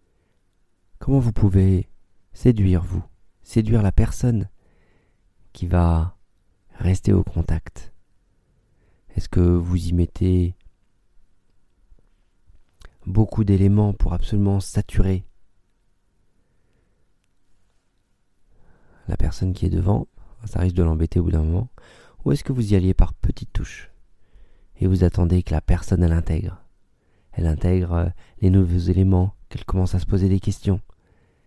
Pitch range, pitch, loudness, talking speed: 90-100 Hz, 95 Hz, -21 LUFS, 125 wpm